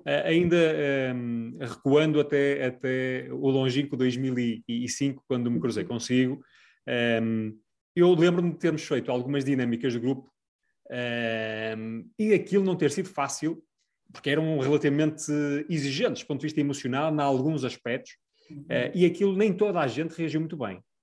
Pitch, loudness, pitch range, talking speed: 140 Hz, -27 LUFS, 125-155 Hz, 145 wpm